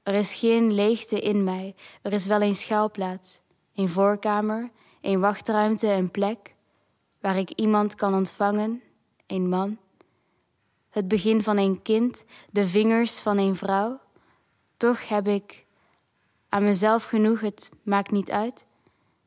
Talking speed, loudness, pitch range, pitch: 135 wpm, -24 LUFS, 195-220 Hz, 205 Hz